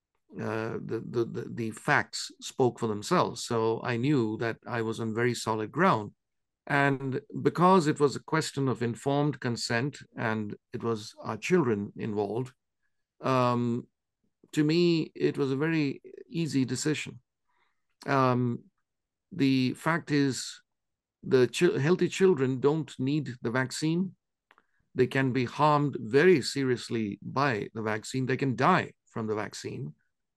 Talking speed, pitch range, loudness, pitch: 140 wpm, 115-150 Hz, -28 LUFS, 130 Hz